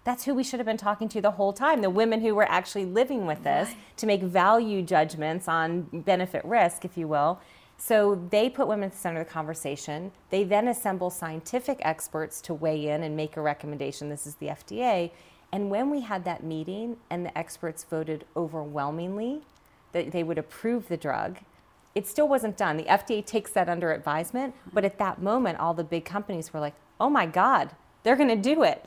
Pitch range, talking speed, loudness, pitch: 160-220 Hz, 210 wpm, -27 LUFS, 185 Hz